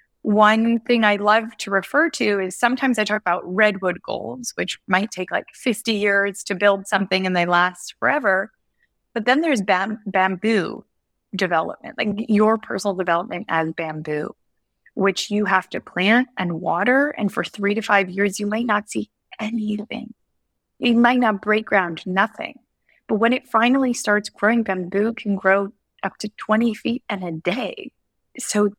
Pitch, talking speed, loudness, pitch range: 210 Hz, 165 wpm, -20 LUFS, 195-230 Hz